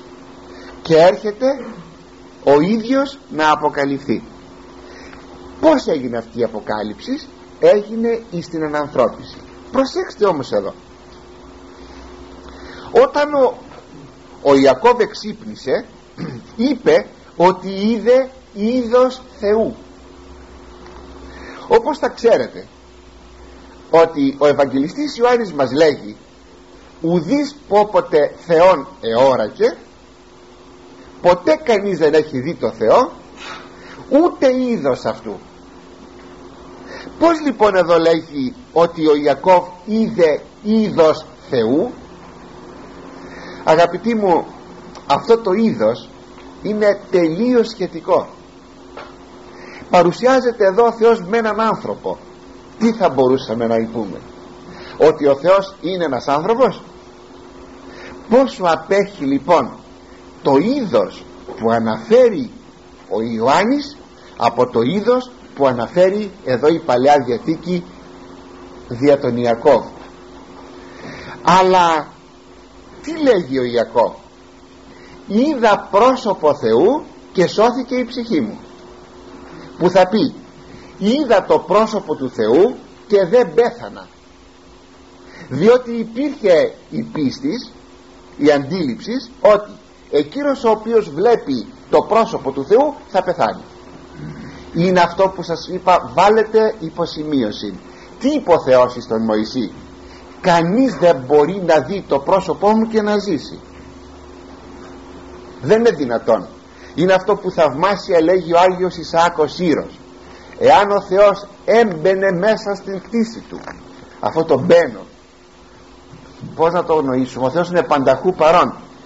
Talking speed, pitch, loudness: 105 wpm, 175 Hz, -16 LUFS